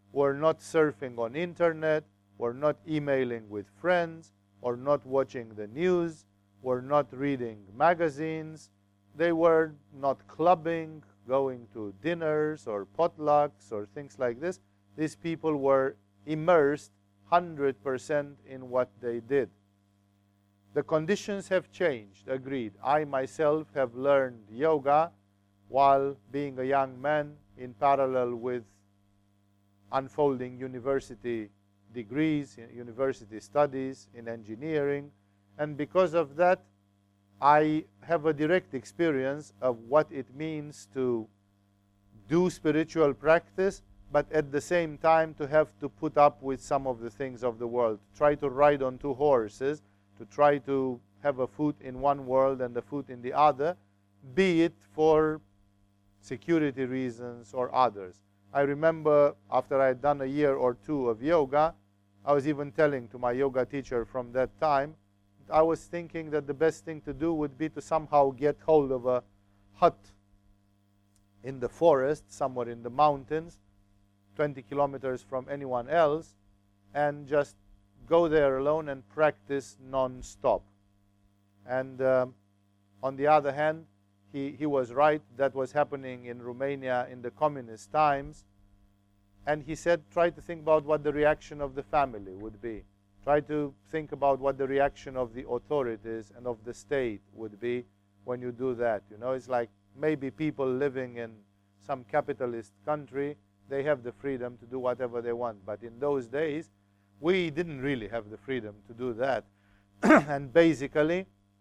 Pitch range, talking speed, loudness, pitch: 110-150 Hz, 150 wpm, -29 LUFS, 135 Hz